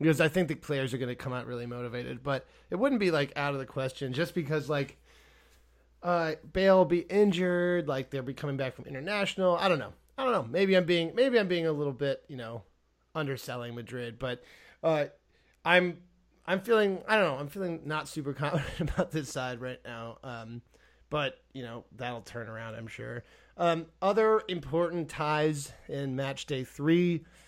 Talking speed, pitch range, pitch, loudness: 190 wpm, 130-175 Hz, 150 Hz, -30 LUFS